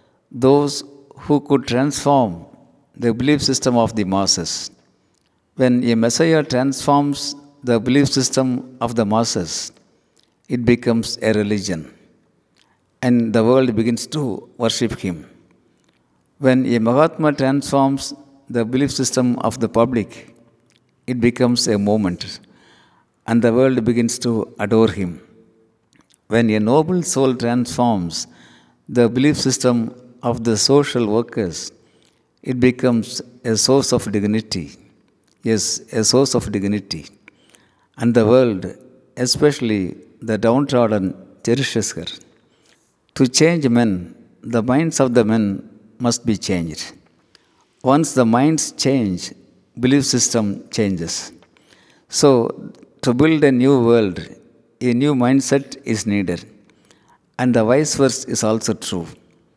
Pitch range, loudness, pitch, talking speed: 110-130 Hz, -18 LUFS, 120 Hz, 120 wpm